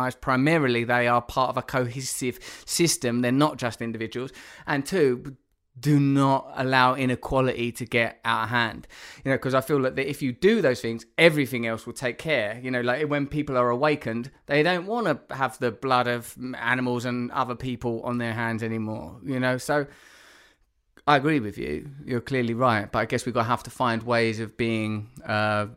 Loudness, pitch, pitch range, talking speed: -25 LUFS, 125 Hz, 120-135 Hz, 200 wpm